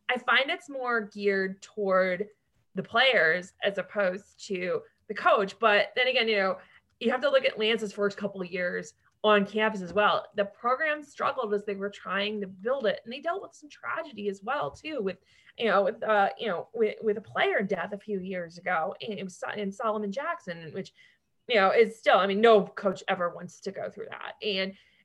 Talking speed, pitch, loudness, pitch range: 210 wpm, 205 Hz, -28 LUFS, 190-240 Hz